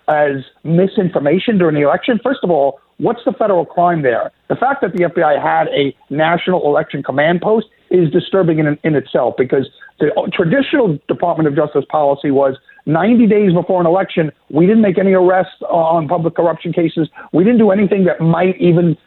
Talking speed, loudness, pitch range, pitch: 185 wpm, -14 LUFS, 155-195 Hz, 175 Hz